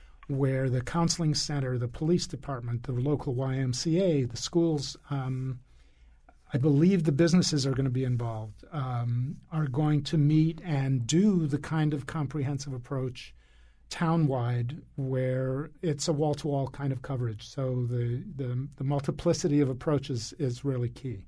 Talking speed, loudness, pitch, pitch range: 150 wpm, -29 LUFS, 135 Hz, 125-155 Hz